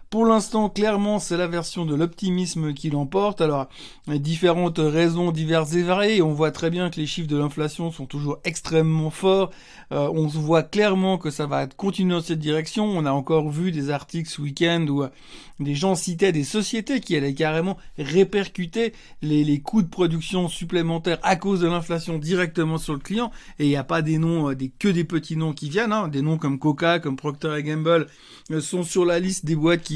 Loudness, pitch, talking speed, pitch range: -23 LUFS, 165 Hz, 210 wpm, 155-185 Hz